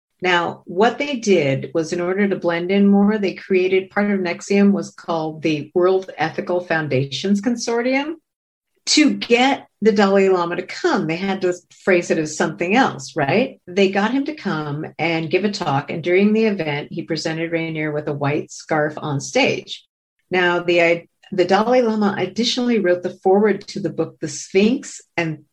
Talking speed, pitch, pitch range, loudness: 180 wpm, 180 Hz, 165-205 Hz, -19 LUFS